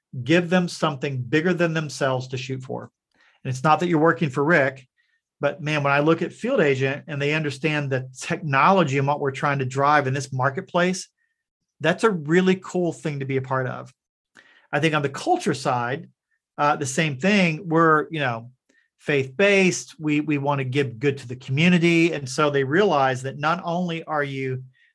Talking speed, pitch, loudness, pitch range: 195 wpm, 150 Hz, -22 LUFS, 135-170 Hz